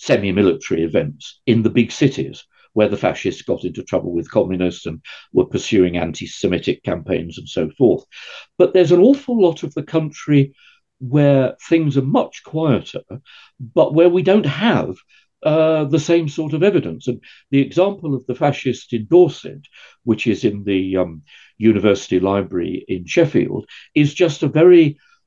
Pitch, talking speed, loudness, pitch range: 145 Hz, 165 wpm, -17 LUFS, 115-170 Hz